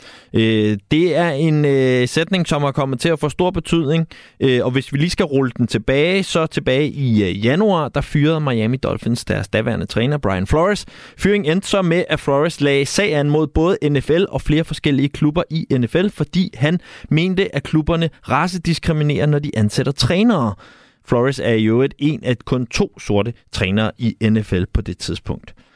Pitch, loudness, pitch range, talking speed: 145 Hz, -18 LUFS, 120-165 Hz, 175 wpm